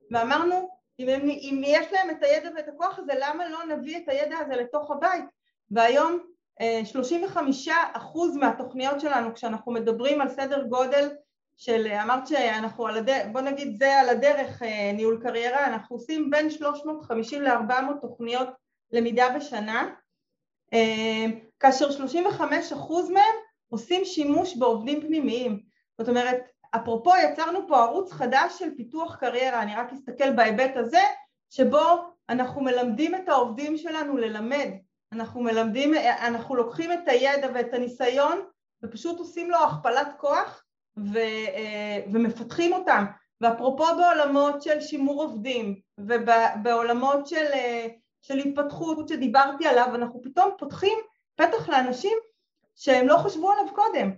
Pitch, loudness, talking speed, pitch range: 275 Hz, -25 LUFS, 125 wpm, 235-315 Hz